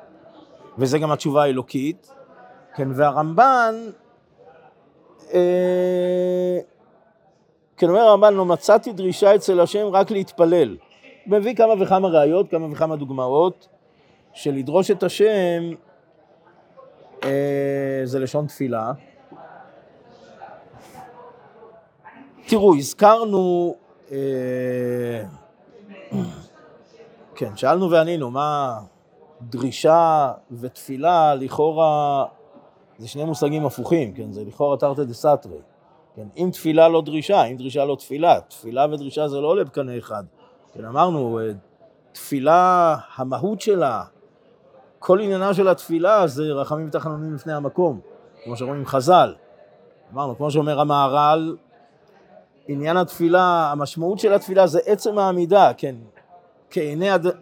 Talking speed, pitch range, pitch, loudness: 105 wpm, 140-185 Hz, 160 Hz, -19 LUFS